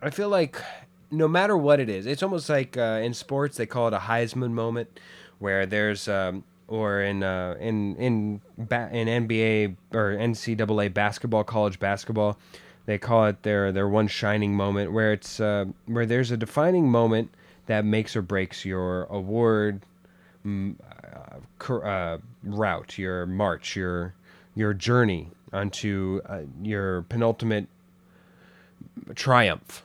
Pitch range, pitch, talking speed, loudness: 95-115 Hz, 105 Hz, 140 wpm, -26 LUFS